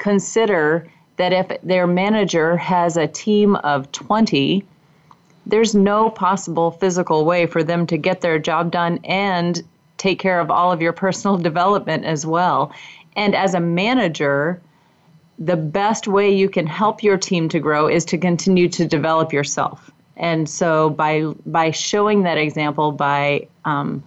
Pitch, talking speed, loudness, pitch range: 170 Hz, 155 wpm, -18 LUFS, 160-190 Hz